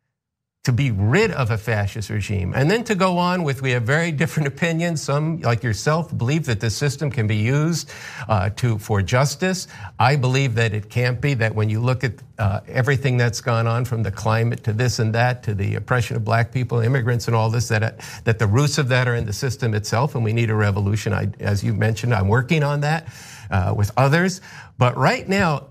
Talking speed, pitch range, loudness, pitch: 215 wpm, 110-140 Hz, -21 LUFS, 120 Hz